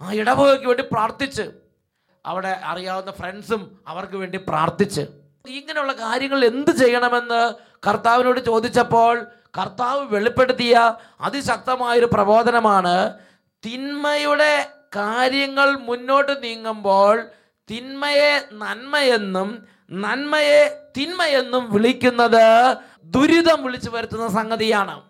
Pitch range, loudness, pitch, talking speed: 210-270 Hz, -19 LUFS, 235 Hz, 80 wpm